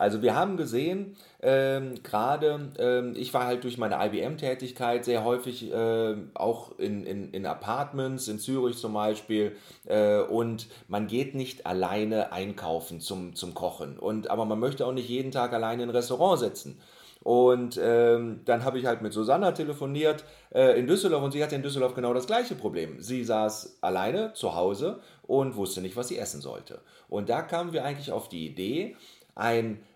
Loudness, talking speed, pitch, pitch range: -28 LUFS, 180 wpm, 120 Hz, 110-135 Hz